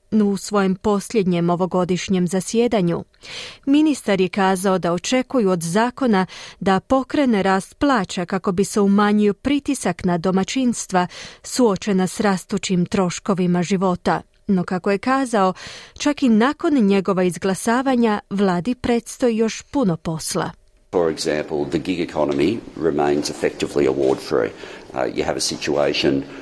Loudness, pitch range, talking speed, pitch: -20 LUFS, 185-235 Hz, 125 wpm, 200 Hz